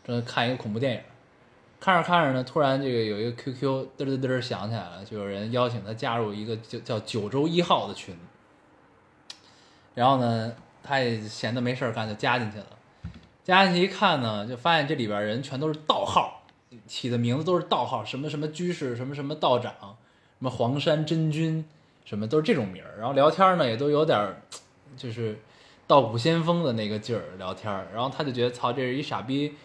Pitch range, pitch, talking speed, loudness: 110-145 Hz, 125 Hz, 305 characters per minute, -26 LUFS